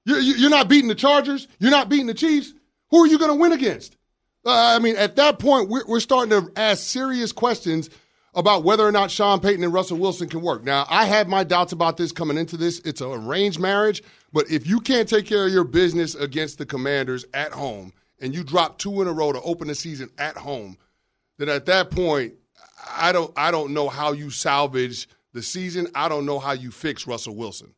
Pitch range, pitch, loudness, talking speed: 150-220 Hz, 175 Hz, -20 LUFS, 220 wpm